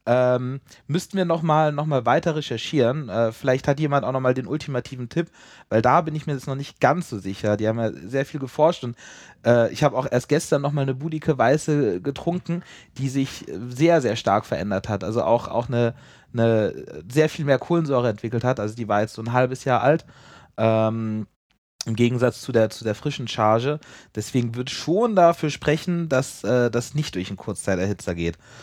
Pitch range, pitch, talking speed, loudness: 115-150 Hz, 130 Hz, 200 wpm, -23 LUFS